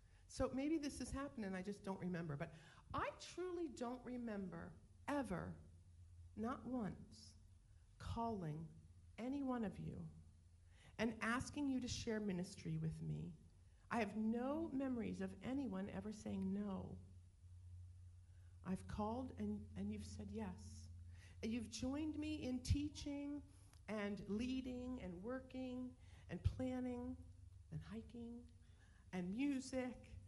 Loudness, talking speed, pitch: -47 LUFS, 125 wpm, 185 Hz